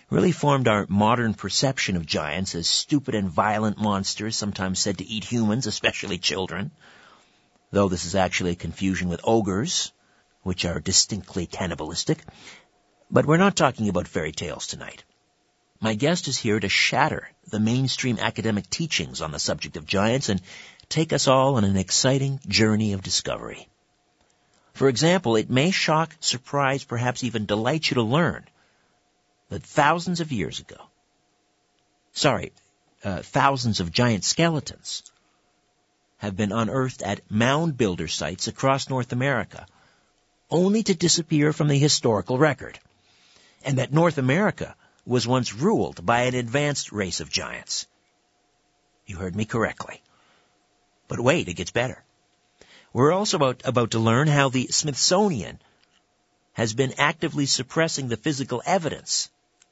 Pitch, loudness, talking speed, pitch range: 115 Hz, -23 LUFS, 145 wpm, 100-140 Hz